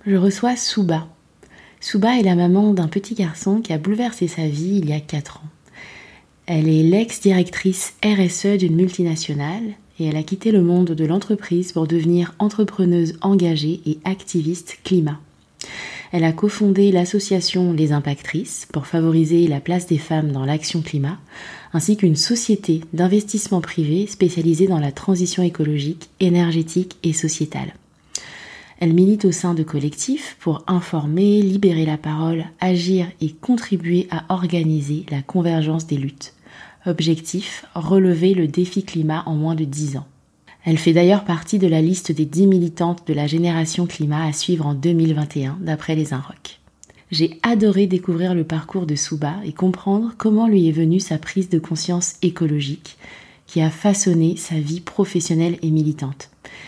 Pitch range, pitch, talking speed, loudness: 160-190 Hz, 170 Hz, 155 wpm, -19 LUFS